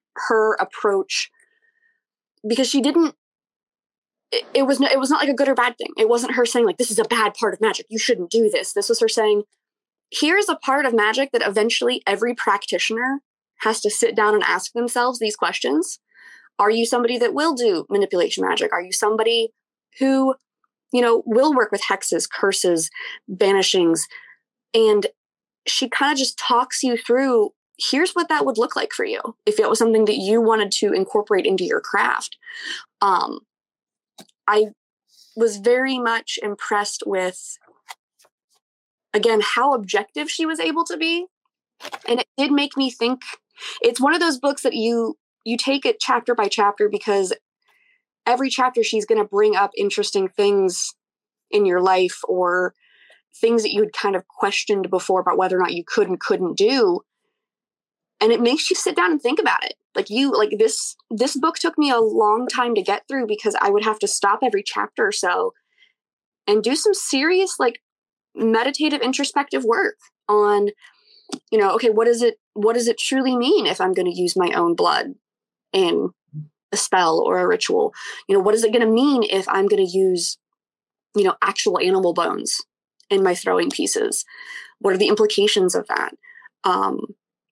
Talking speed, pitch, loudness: 185 wpm, 255 Hz, -20 LUFS